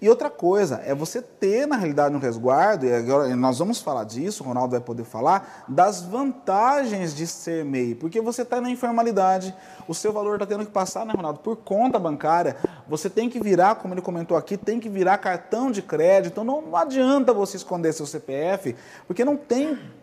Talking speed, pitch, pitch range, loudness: 200 wpm, 190 Hz, 160-230 Hz, -23 LUFS